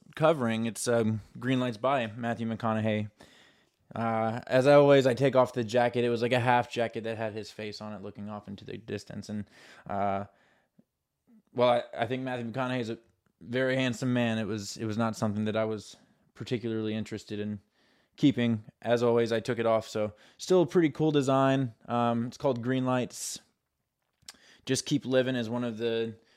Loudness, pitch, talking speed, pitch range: -29 LUFS, 115 Hz, 190 wpm, 110-130 Hz